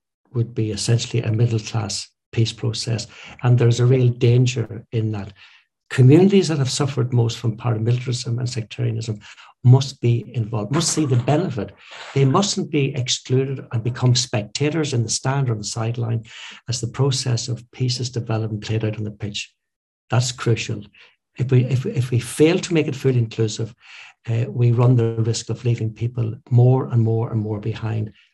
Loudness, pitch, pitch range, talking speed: -21 LUFS, 120 Hz, 115-130 Hz, 180 wpm